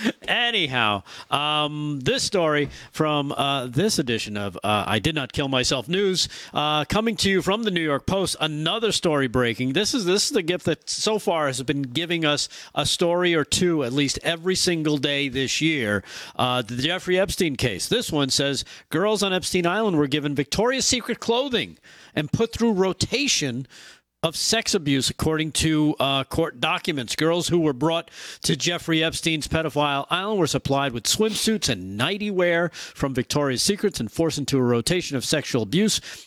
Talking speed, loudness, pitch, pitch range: 180 wpm, -23 LUFS, 155 Hz, 140-180 Hz